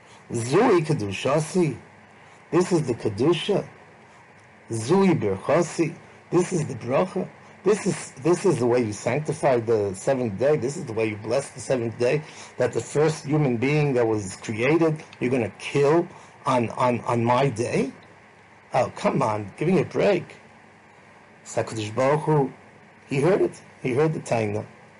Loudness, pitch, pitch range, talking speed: -24 LUFS, 130 Hz, 115-160 Hz, 150 wpm